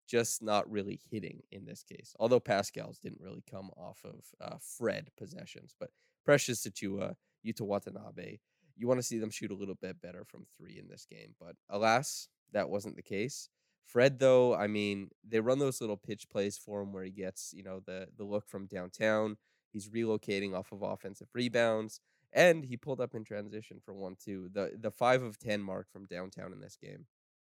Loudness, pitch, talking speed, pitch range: -34 LUFS, 105 Hz, 200 wpm, 100-115 Hz